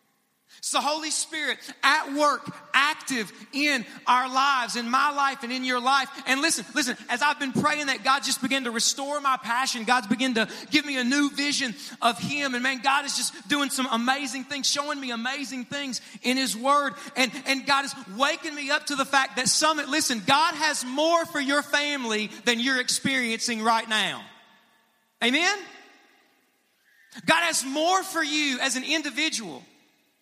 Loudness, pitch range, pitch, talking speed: -24 LUFS, 250-290 Hz, 270 Hz, 180 wpm